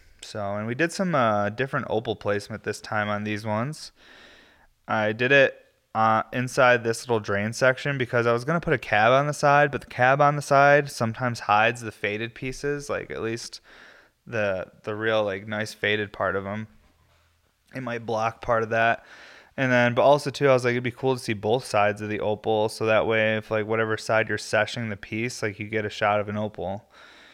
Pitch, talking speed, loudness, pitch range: 110 Hz, 220 wpm, -24 LUFS, 105-125 Hz